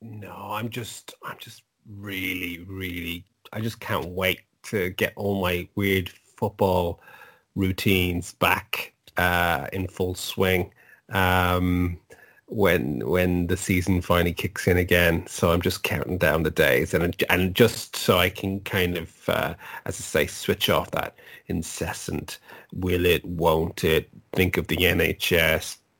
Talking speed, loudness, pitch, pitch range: 145 wpm, -24 LUFS, 95 Hz, 90-100 Hz